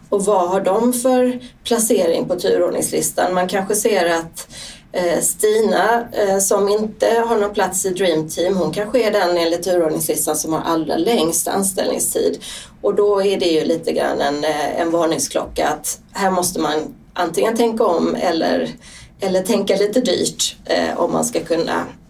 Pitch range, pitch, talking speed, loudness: 170-225 Hz, 195 Hz, 160 wpm, -18 LUFS